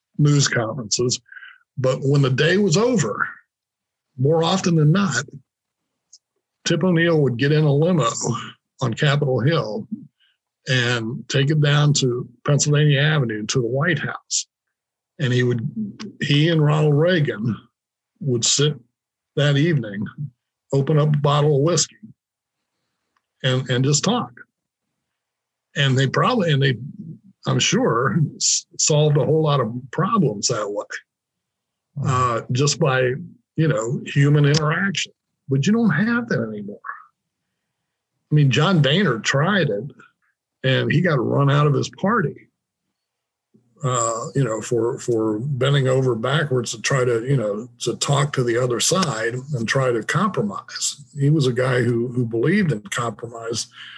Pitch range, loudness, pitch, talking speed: 125-155 Hz, -20 LUFS, 140 Hz, 140 wpm